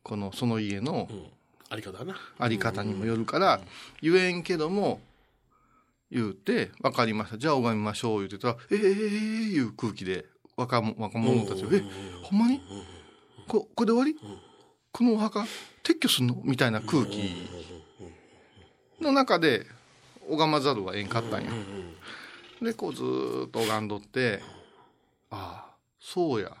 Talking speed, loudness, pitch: 270 characters per minute, -28 LUFS, 120 Hz